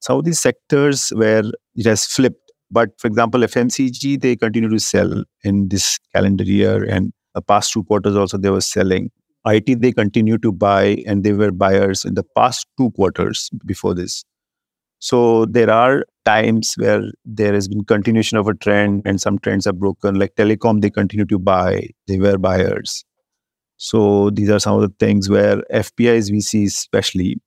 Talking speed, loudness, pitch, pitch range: 180 wpm, -16 LUFS, 105 Hz, 100-115 Hz